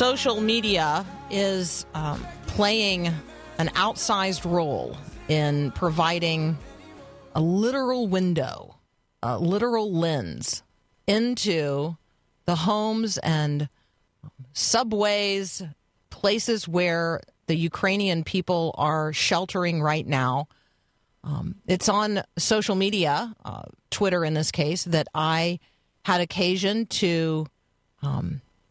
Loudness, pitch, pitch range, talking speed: -25 LUFS, 170 Hz, 150-200 Hz, 95 wpm